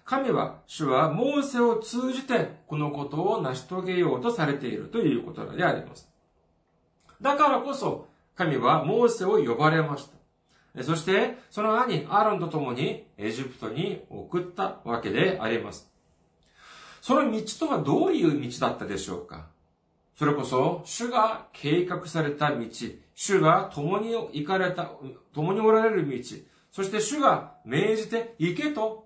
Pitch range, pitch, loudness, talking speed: 150-230 Hz, 190 Hz, -26 LUFS, 285 characters per minute